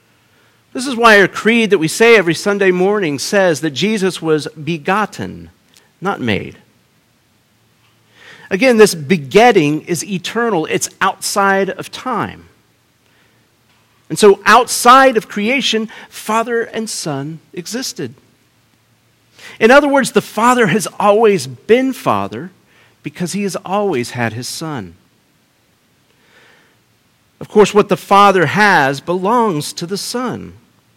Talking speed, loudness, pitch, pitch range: 120 wpm, -13 LUFS, 190 Hz, 150-220 Hz